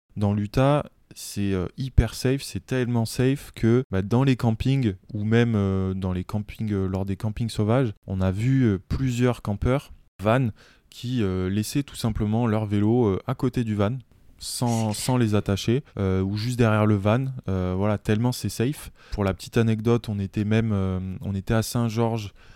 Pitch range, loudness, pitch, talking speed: 100-120 Hz, -25 LUFS, 110 Hz, 190 wpm